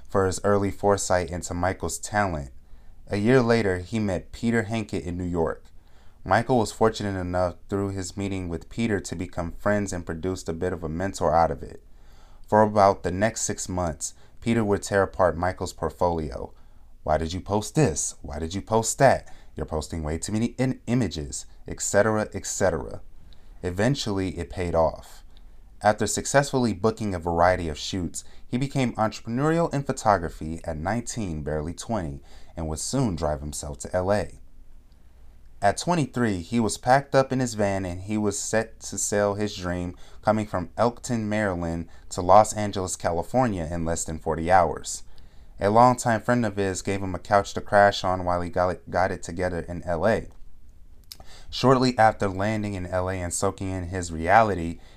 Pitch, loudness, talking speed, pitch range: 95 Hz, -25 LUFS, 170 wpm, 85-110 Hz